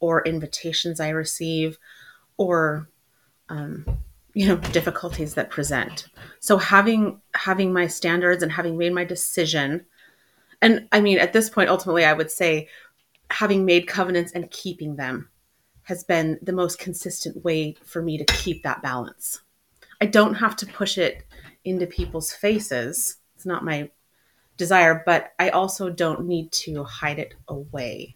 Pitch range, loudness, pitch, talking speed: 155-185 Hz, -22 LUFS, 170 Hz, 150 wpm